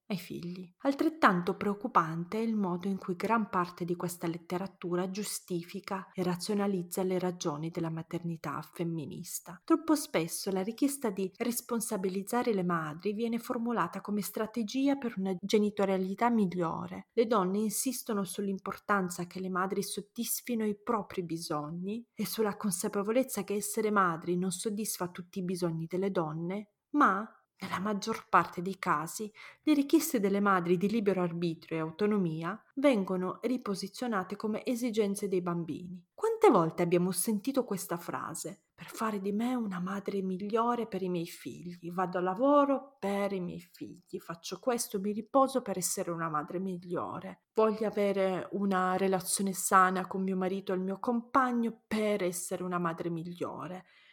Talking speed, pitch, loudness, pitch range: 145 wpm, 195 Hz, -32 LUFS, 180-220 Hz